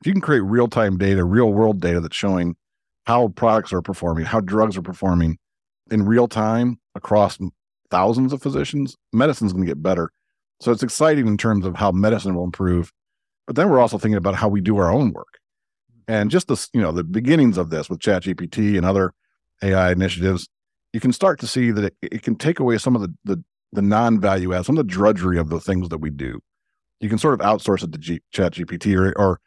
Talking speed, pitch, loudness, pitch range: 225 wpm, 105 Hz, -20 LUFS, 95-115 Hz